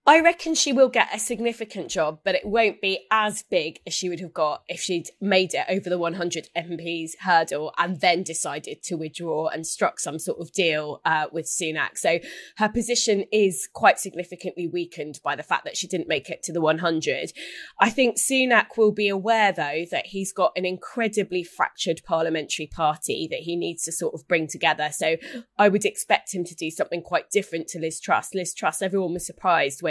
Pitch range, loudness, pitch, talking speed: 165-205 Hz, -24 LUFS, 180 Hz, 205 wpm